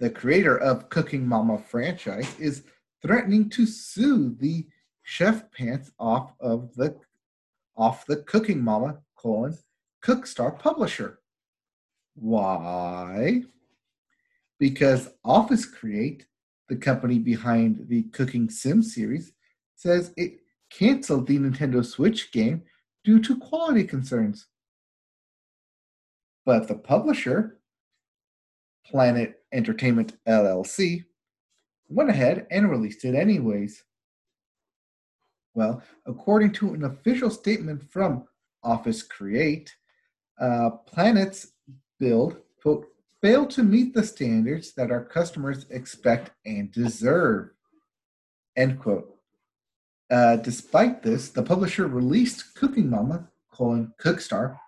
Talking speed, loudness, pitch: 100 wpm, -24 LUFS, 145 Hz